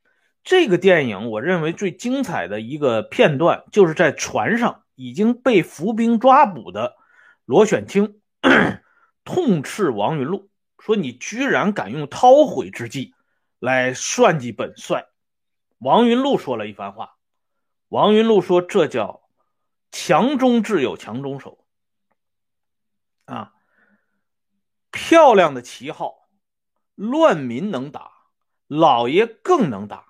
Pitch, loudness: 205 Hz, -18 LUFS